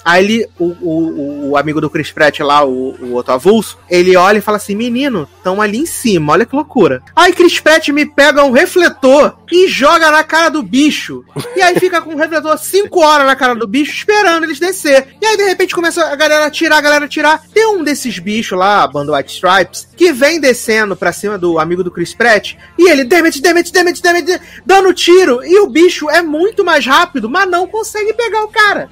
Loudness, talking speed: -10 LUFS, 220 wpm